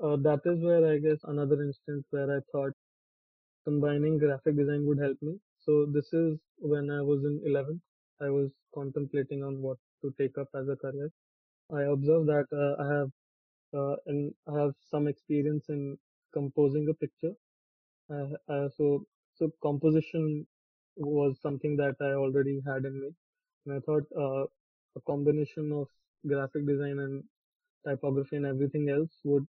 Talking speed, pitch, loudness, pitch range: 160 wpm, 145 Hz, -31 LUFS, 140-150 Hz